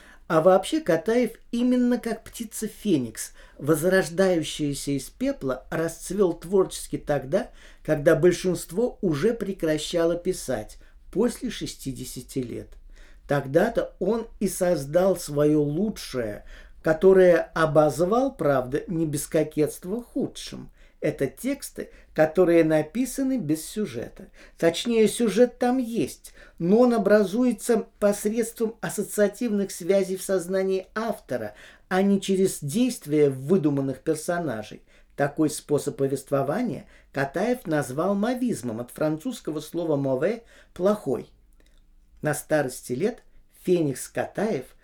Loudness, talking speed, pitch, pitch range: -25 LUFS, 100 wpm, 180 Hz, 150-215 Hz